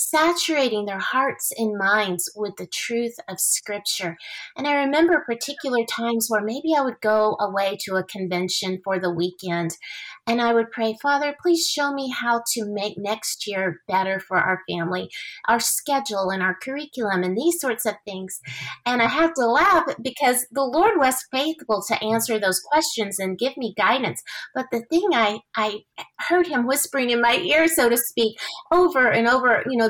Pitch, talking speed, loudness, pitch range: 230 Hz, 185 wpm, -22 LUFS, 200-275 Hz